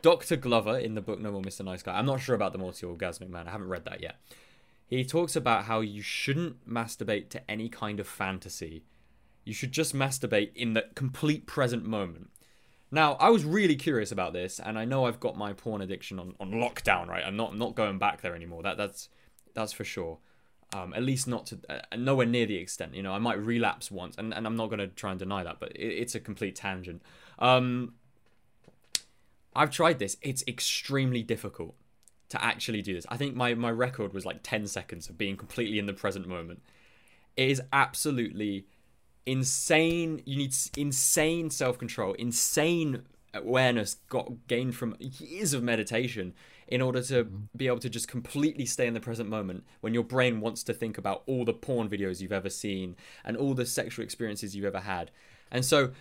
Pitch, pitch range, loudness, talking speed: 115 Hz, 100-125 Hz, -30 LUFS, 200 wpm